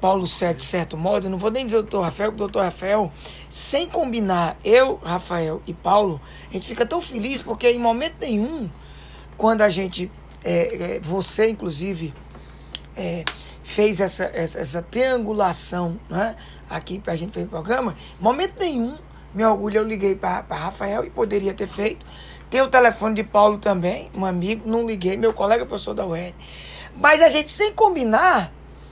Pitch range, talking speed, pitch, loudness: 180-230 Hz, 175 wpm, 205 Hz, -21 LUFS